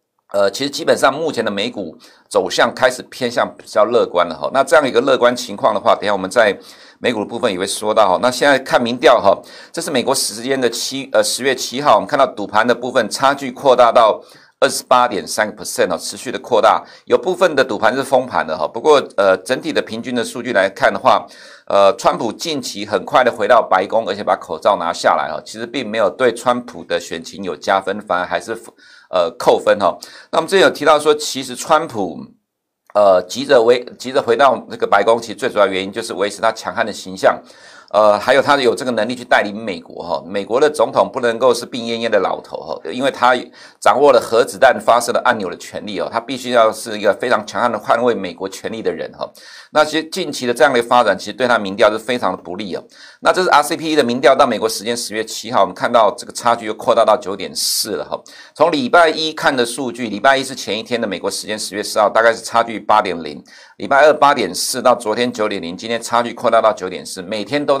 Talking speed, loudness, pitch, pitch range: 355 characters per minute, -16 LUFS, 120 Hz, 110-140 Hz